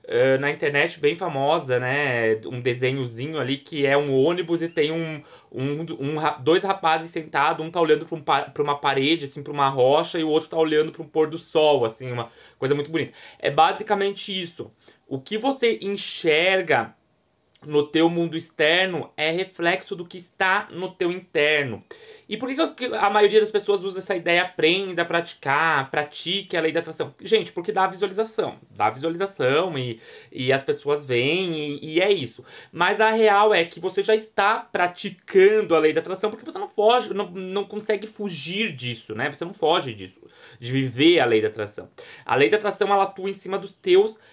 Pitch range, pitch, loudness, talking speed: 150-200 Hz, 170 Hz, -22 LUFS, 190 wpm